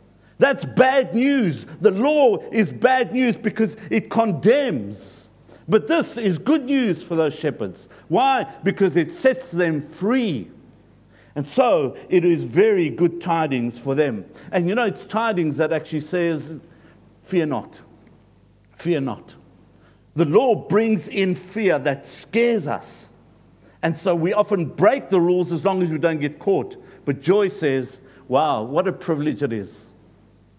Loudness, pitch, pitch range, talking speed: -21 LUFS, 175 Hz, 145-215 Hz, 150 wpm